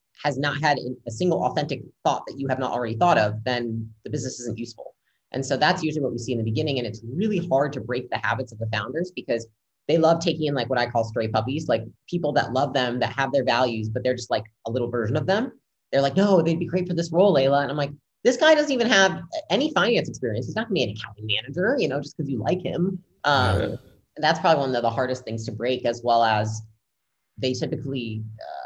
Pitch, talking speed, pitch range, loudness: 130 Hz, 255 wpm, 115-155 Hz, -24 LUFS